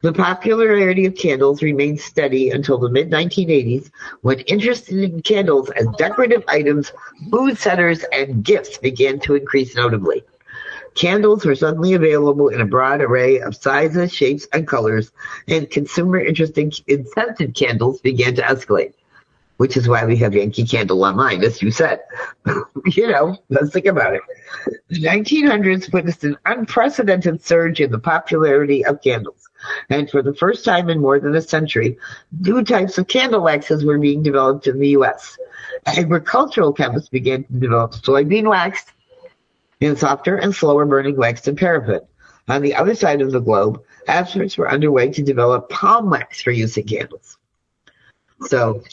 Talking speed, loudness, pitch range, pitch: 160 wpm, -17 LUFS, 135-185 Hz, 145 Hz